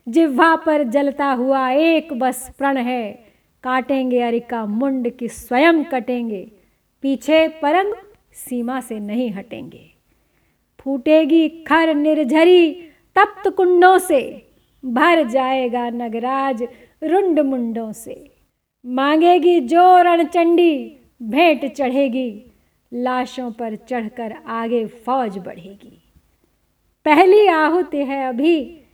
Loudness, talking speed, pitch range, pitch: -17 LUFS, 95 wpm, 245-320 Hz, 270 Hz